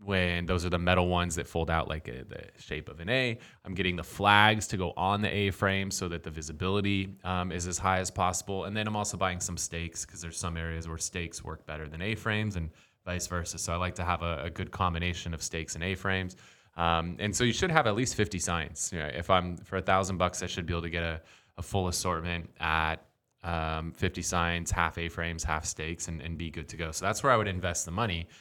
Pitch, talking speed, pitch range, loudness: 90 Hz, 260 wpm, 85-95 Hz, -31 LUFS